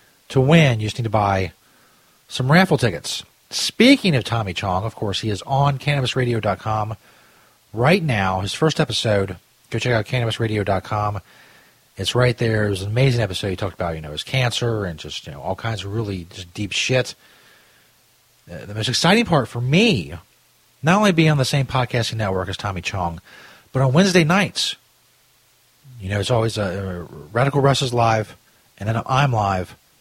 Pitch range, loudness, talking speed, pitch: 100-130 Hz, -20 LUFS, 180 wpm, 115 Hz